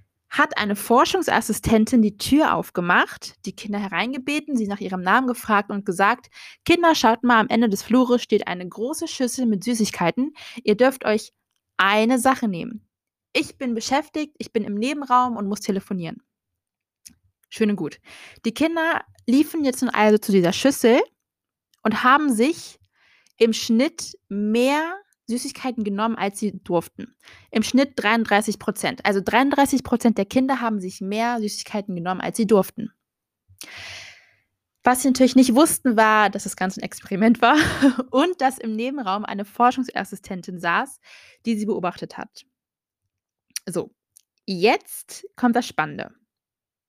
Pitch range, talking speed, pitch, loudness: 205-255 Hz, 145 wpm, 230 Hz, -21 LUFS